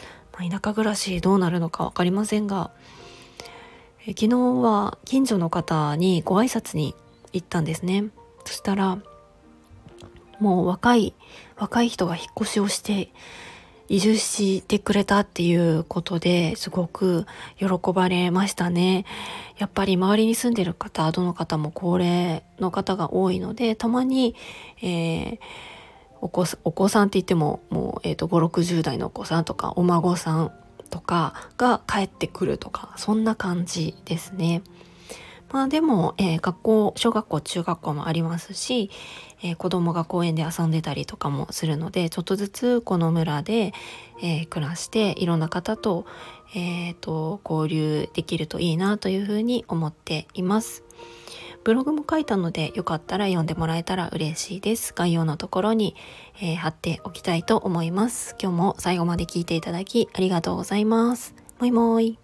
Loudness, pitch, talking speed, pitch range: -24 LUFS, 180 Hz, 305 characters per minute, 165-210 Hz